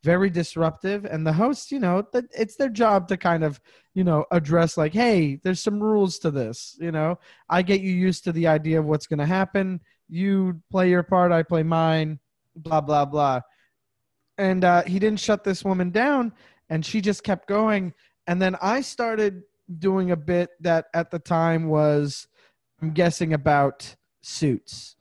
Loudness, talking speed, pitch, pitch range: -23 LUFS, 180 wpm, 175 Hz, 160-195 Hz